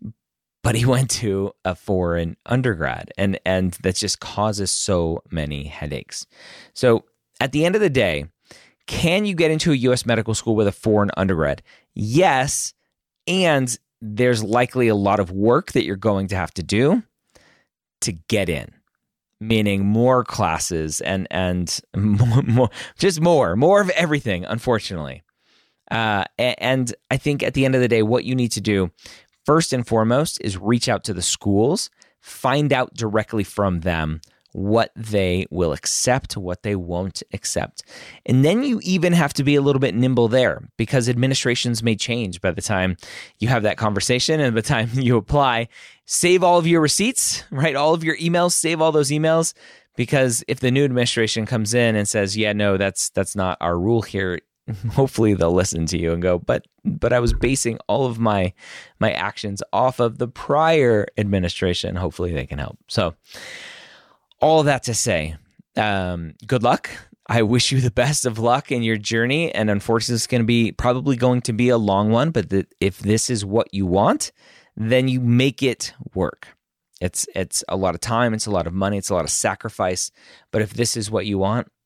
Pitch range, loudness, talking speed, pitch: 95-130 Hz, -20 LUFS, 185 wpm, 115 Hz